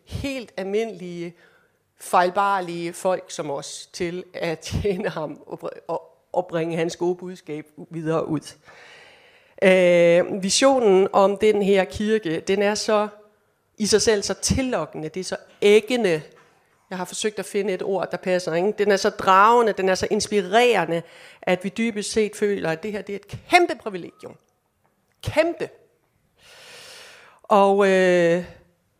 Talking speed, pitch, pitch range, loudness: 145 wpm, 195 Hz, 180-215 Hz, -21 LUFS